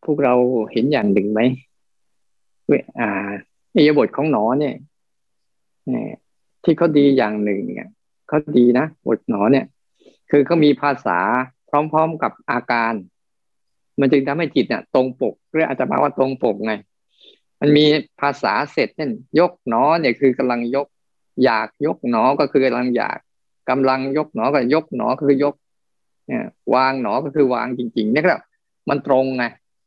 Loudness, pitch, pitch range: -18 LUFS, 135 Hz, 120-145 Hz